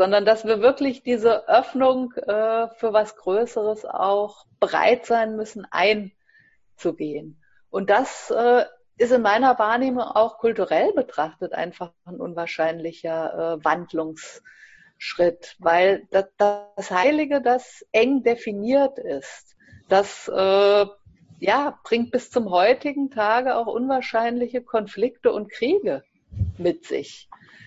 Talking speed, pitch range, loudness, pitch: 115 wpm, 195-250 Hz, -22 LUFS, 220 Hz